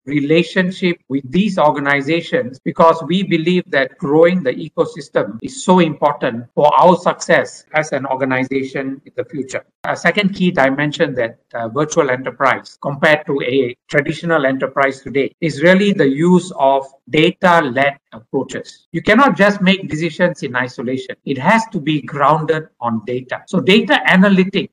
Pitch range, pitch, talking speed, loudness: 135-180 Hz, 155 Hz, 150 wpm, -15 LUFS